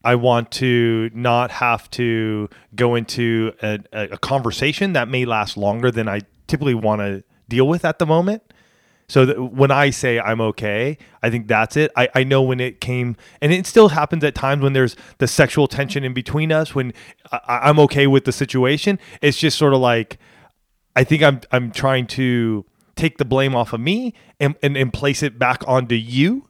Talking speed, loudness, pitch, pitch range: 200 wpm, -18 LUFS, 130 Hz, 115-145 Hz